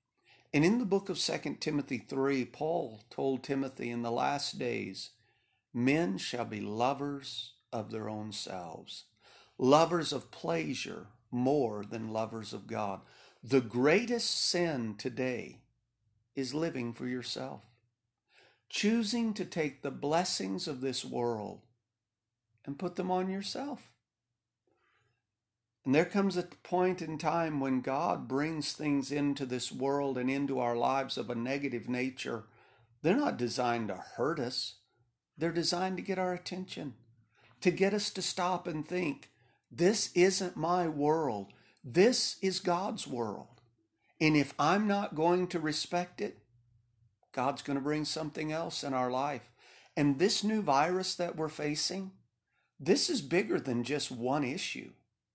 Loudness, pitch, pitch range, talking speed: -33 LUFS, 135 Hz, 120-175 Hz, 145 wpm